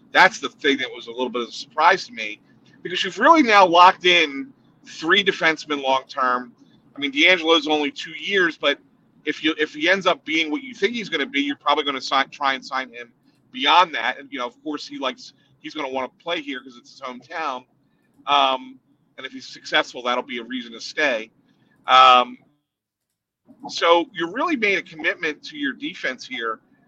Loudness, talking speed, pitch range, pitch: -20 LUFS, 210 wpm, 130-175 Hz, 145 Hz